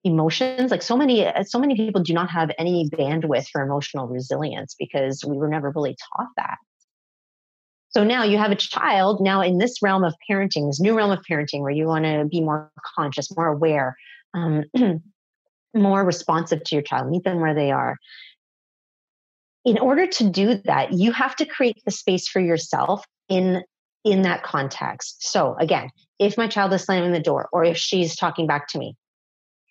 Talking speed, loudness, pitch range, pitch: 185 wpm, -22 LUFS, 155-210 Hz, 175 Hz